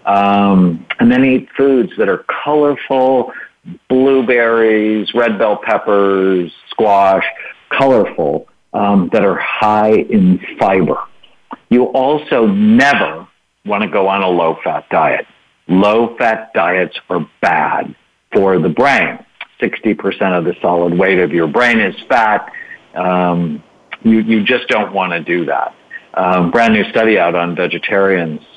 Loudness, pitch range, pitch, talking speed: -13 LUFS, 90-130 Hz, 105 Hz, 140 wpm